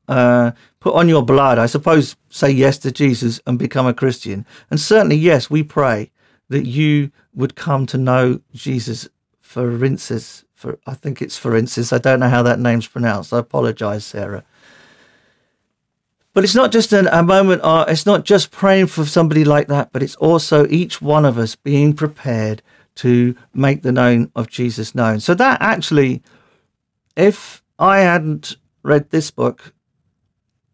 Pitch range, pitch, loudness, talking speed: 120-155 Hz, 135 Hz, -15 LUFS, 170 wpm